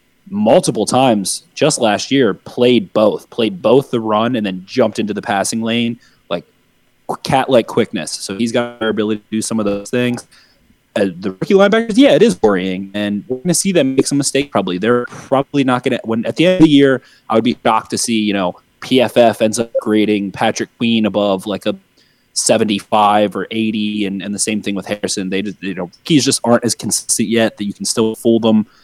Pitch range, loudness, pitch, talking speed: 105-125 Hz, -15 LUFS, 110 Hz, 220 wpm